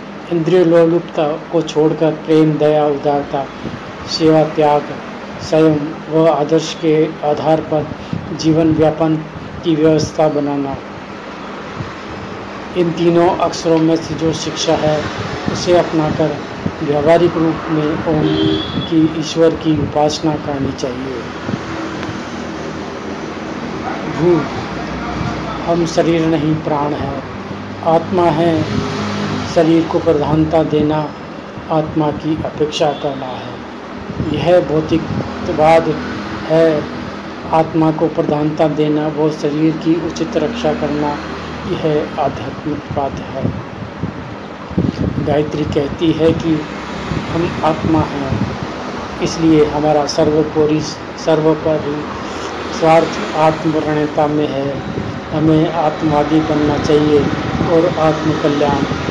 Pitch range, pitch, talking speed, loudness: 150-160 Hz, 155 Hz, 95 wpm, -16 LUFS